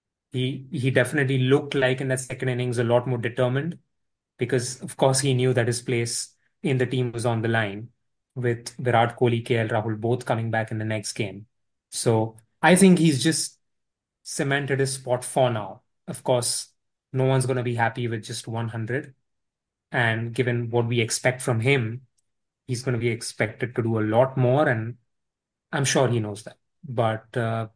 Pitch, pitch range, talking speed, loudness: 125 Hz, 115-130 Hz, 185 wpm, -24 LUFS